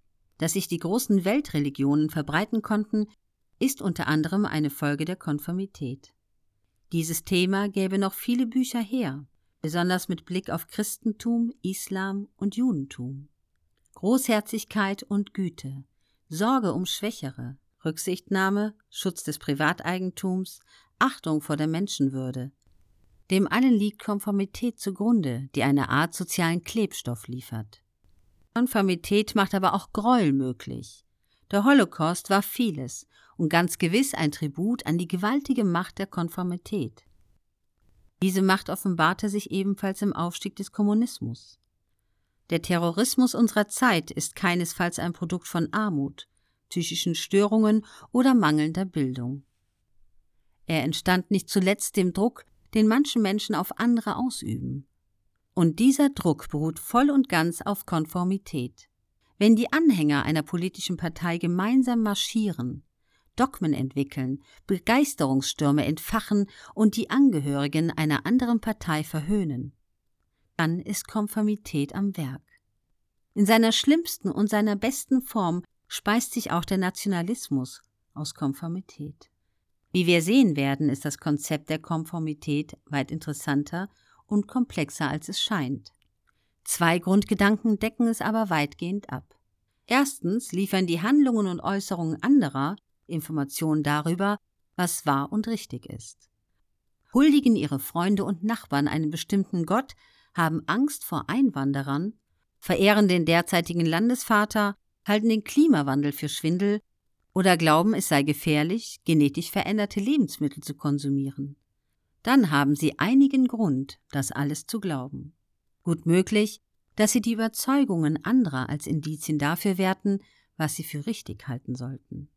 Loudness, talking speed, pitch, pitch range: -25 LUFS, 125 wpm, 175 Hz, 145-210 Hz